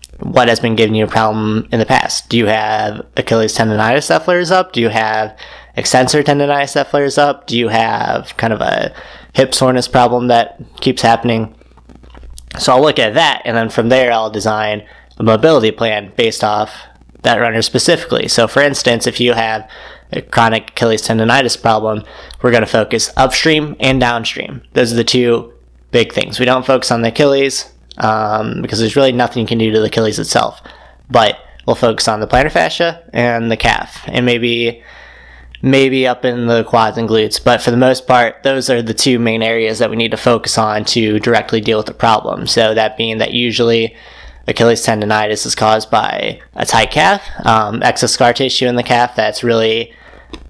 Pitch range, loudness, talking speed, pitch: 110-125 Hz, -13 LUFS, 195 wpm, 115 Hz